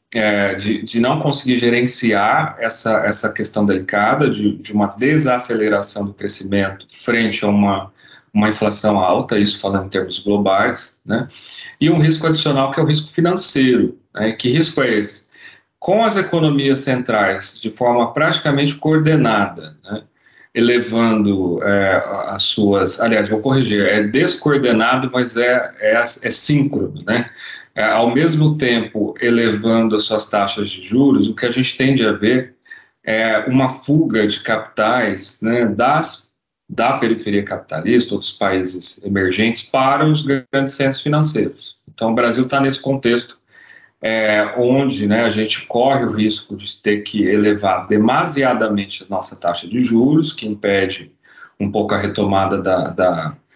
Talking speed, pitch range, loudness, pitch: 150 wpm, 105-135 Hz, -17 LUFS, 115 Hz